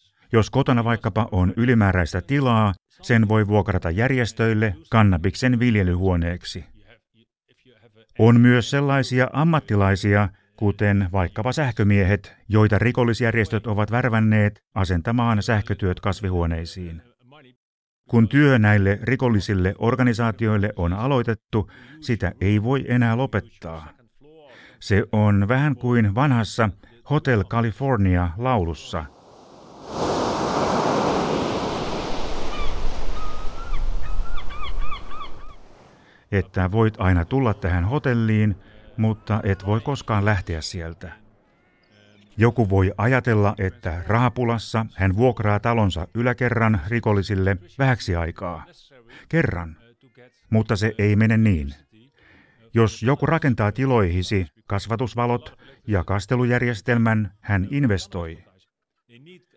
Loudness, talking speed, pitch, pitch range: -21 LUFS, 85 wpm, 110 Hz, 100-120 Hz